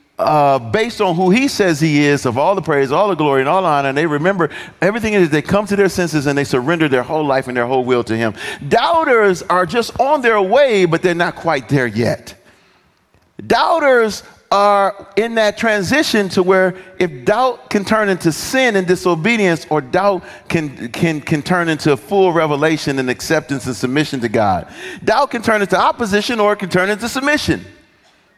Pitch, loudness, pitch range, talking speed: 180 Hz, -15 LUFS, 150-205 Hz, 200 wpm